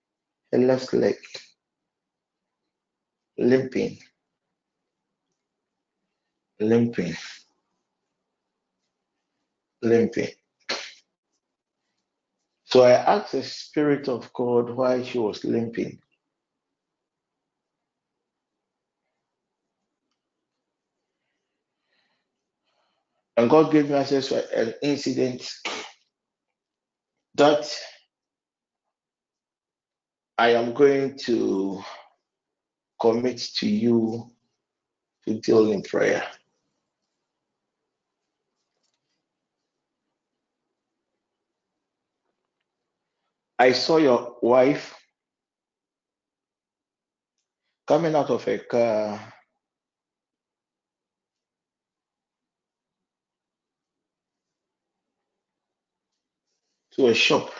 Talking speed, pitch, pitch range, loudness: 50 wpm, 125 Hz, 115-140 Hz, -23 LUFS